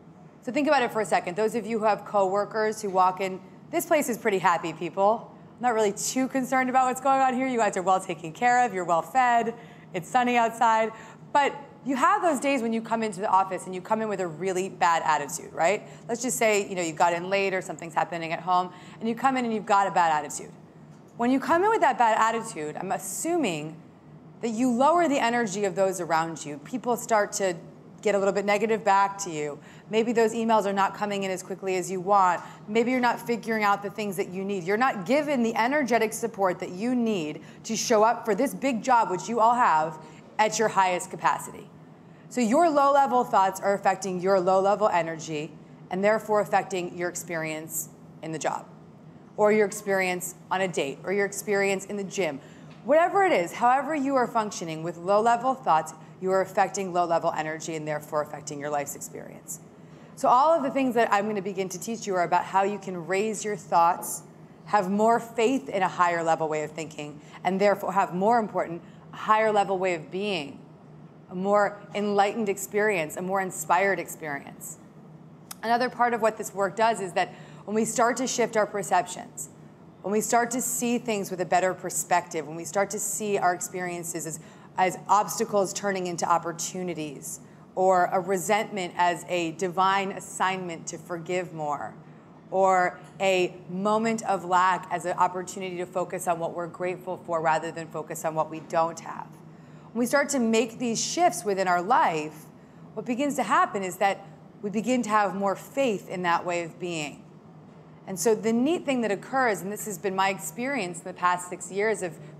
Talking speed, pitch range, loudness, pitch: 205 wpm, 180-225 Hz, -26 LUFS, 195 Hz